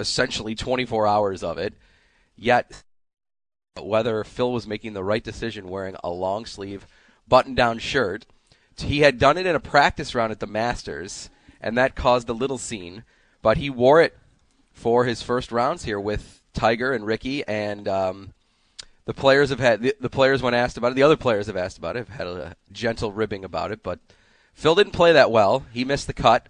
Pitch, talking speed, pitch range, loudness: 115 Hz, 195 wpm, 105-125 Hz, -22 LUFS